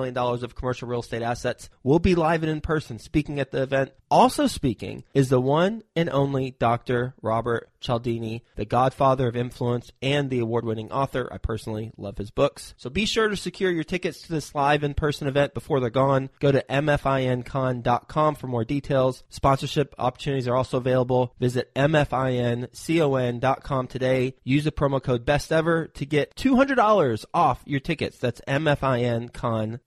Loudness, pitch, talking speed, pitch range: -24 LUFS, 130 Hz, 165 wpm, 120-145 Hz